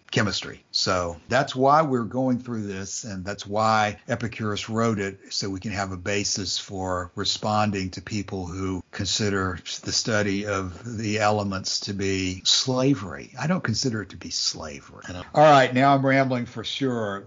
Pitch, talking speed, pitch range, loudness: 105 Hz, 165 wpm, 95-120 Hz, -24 LUFS